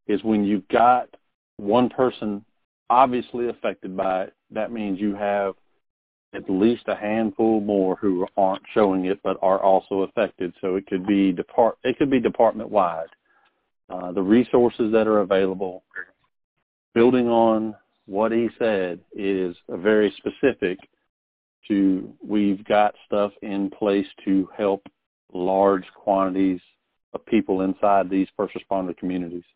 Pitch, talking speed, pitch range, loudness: 100 Hz, 135 wpm, 95-105 Hz, -22 LUFS